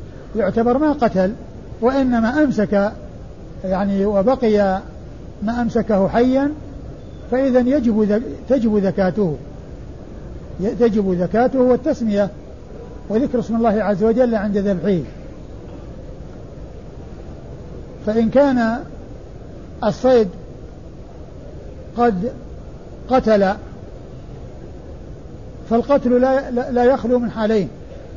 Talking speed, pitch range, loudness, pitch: 75 wpm, 200-245 Hz, -18 LUFS, 225 Hz